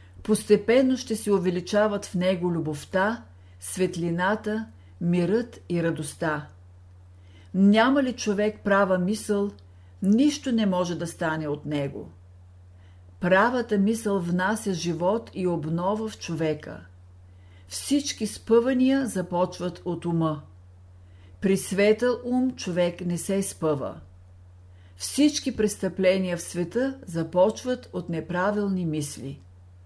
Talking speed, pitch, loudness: 100 wpm, 180 Hz, -25 LUFS